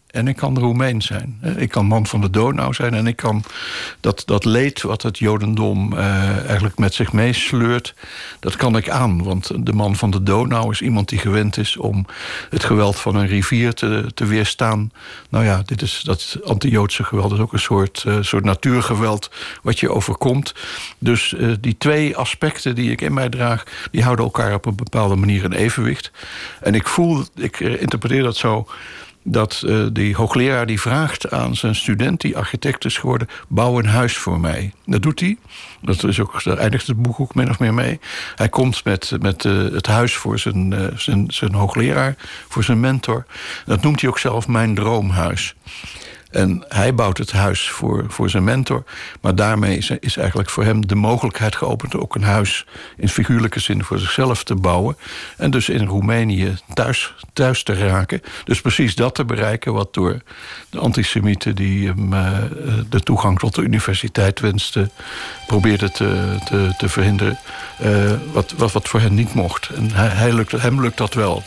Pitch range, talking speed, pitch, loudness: 100-120 Hz, 190 wpm, 110 Hz, -18 LUFS